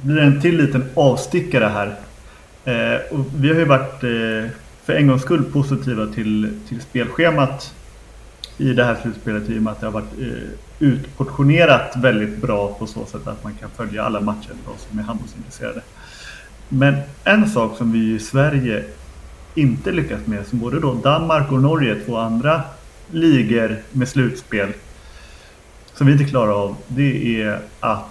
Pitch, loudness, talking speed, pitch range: 120 Hz, -18 LUFS, 165 wpm, 105-140 Hz